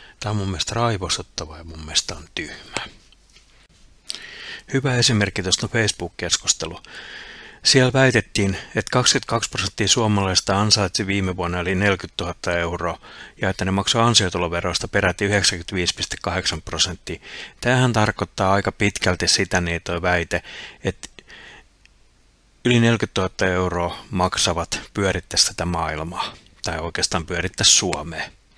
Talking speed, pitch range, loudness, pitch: 120 wpm, 85-105 Hz, -20 LUFS, 95 Hz